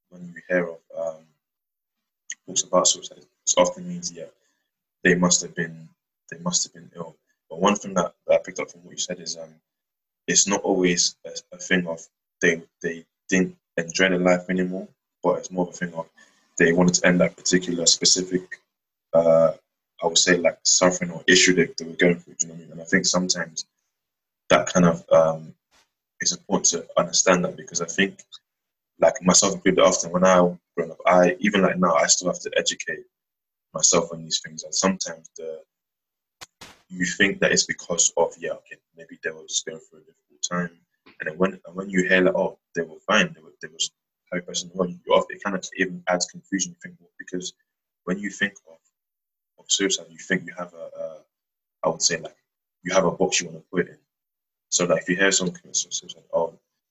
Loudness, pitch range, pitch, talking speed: -22 LUFS, 85-95 Hz, 90 Hz, 215 wpm